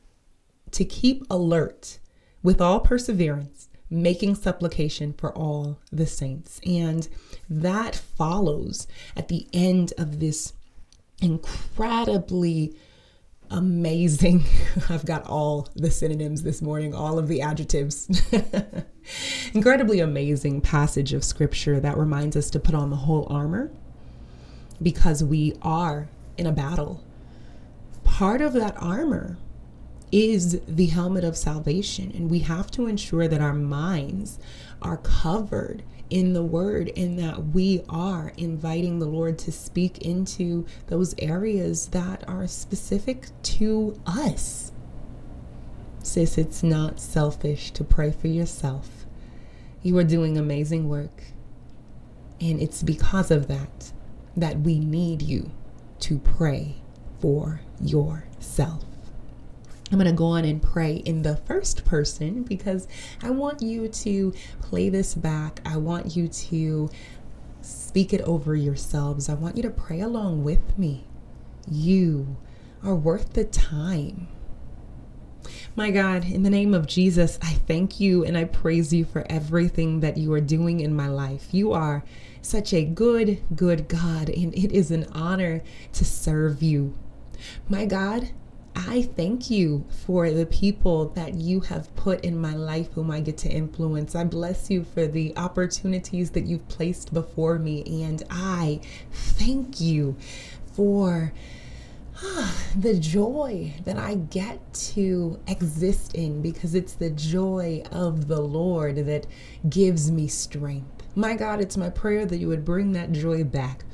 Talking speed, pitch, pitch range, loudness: 140 wpm, 165 Hz, 150-185 Hz, -25 LUFS